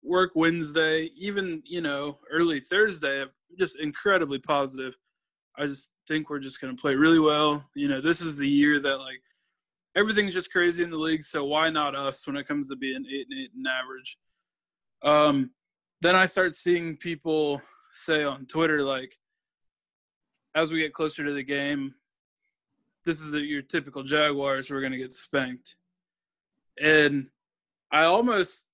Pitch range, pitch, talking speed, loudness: 140-170 Hz, 150 Hz, 165 wpm, -26 LUFS